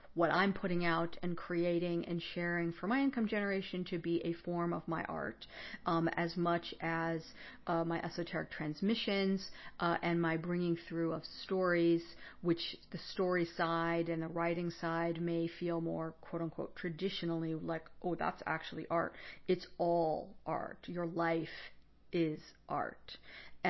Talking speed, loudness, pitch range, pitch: 150 wpm, -37 LUFS, 165-175 Hz, 170 Hz